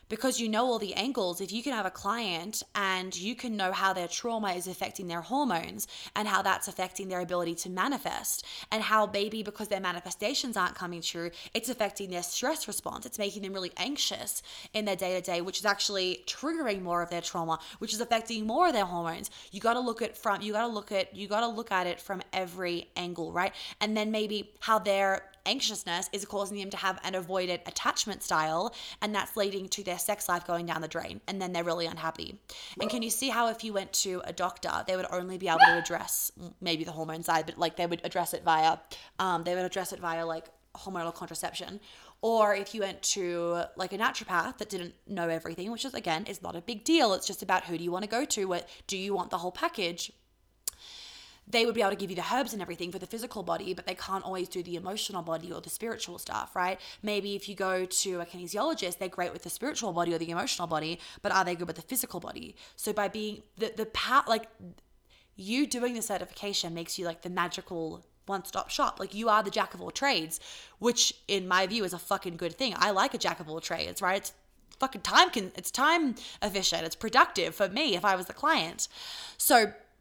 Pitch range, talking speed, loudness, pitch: 175-220 Hz, 230 wpm, -31 LUFS, 195 Hz